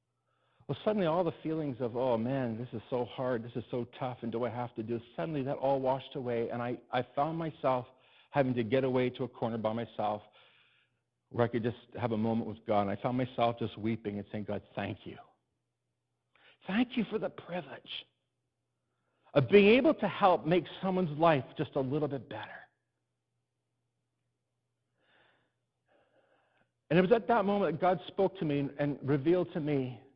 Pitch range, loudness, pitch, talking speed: 115-155 Hz, -32 LUFS, 130 Hz, 185 wpm